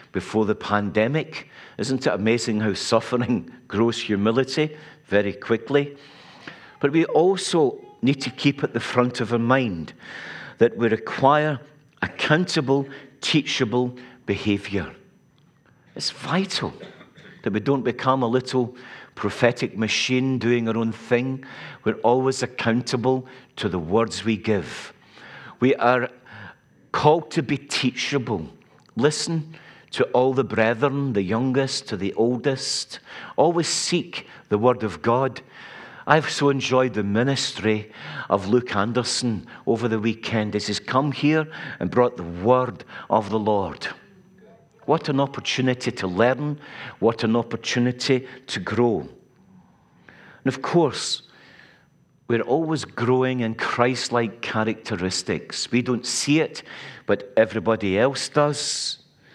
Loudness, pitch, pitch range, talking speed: -23 LUFS, 125 Hz, 110-135 Hz, 125 wpm